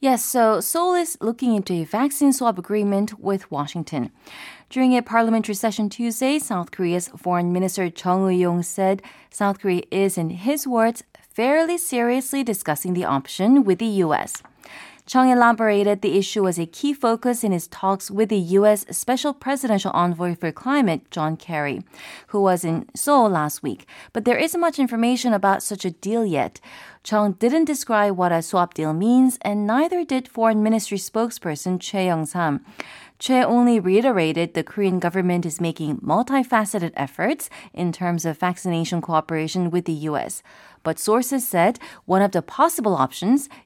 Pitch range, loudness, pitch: 175-245 Hz, -21 LUFS, 205 Hz